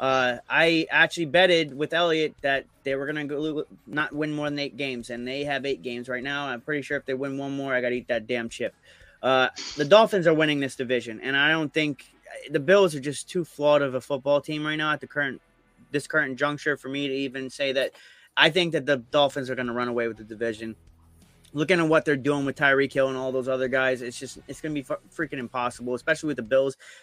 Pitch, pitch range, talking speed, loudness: 140 Hz, 130-150 Hz, 250 wpm, -25 LUFS